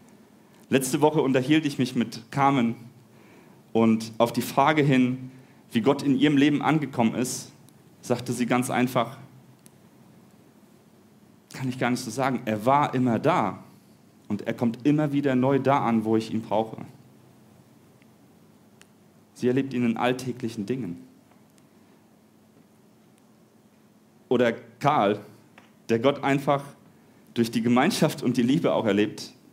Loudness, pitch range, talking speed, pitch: -24 LUFS, 115-135 Hz, 130 wpm, 125 Hz